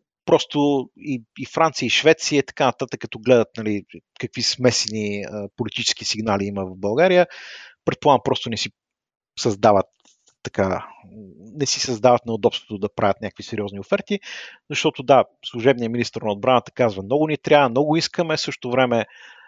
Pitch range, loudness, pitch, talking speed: 110-140 Hz, -21 LUFS, 125 Hz, 145 wpm